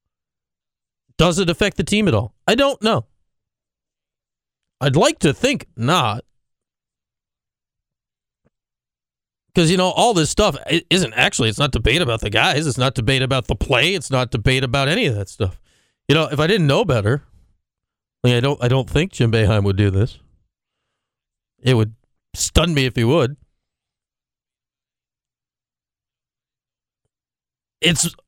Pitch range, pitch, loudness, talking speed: 105-160 Hz, 130 Hz, -18 LUFS, 150 wpm